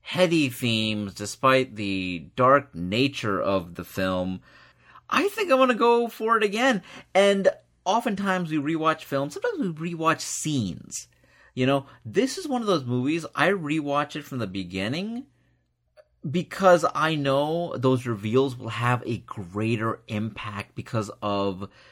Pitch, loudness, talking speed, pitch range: 140 Hz, -25 LUFS, 140 wpm, 110-180 Hz